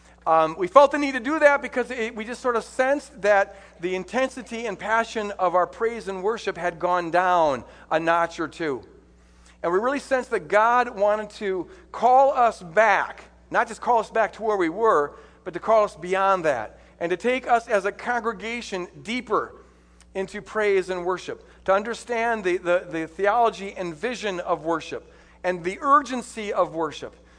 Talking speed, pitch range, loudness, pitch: 185 wpm, 180-235 Hz, -23 LUFS, 210 Hz